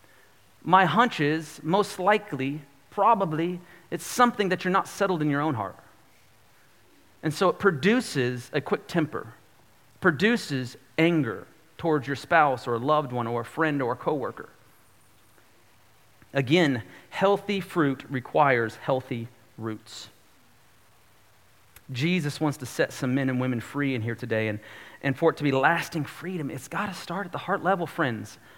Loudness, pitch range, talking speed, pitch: -26 LUFS, 120-170 Hz, 155 wpm, 140 Hz